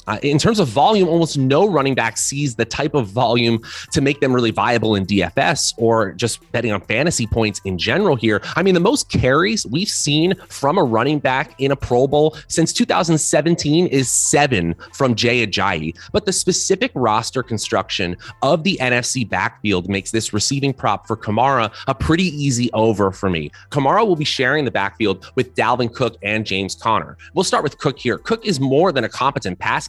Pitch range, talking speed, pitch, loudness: 110-150 Hz, 195 wpm, 125 Hz, -18 LUFS